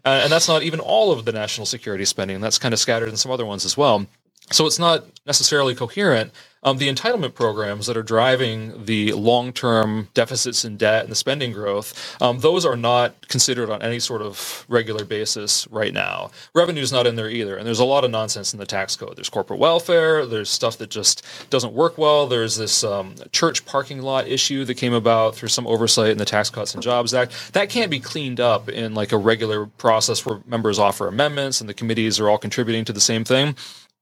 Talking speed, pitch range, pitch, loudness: 220 wpm, 110-135 Hz, 115 Hz, -20 LUFS